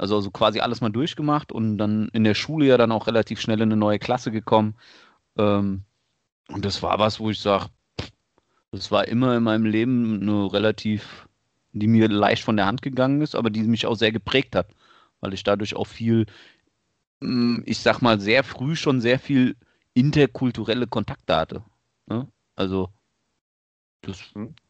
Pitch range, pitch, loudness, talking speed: 105-120 Hz, 110 Hz, -22 LUFS, 170 wpm